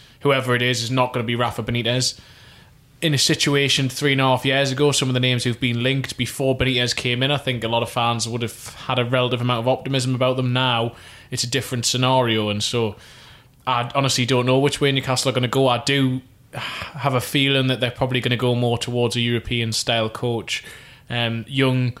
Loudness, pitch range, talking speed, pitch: -20 LUFS, 120-135 Hz, 225 wpm, 125 Hz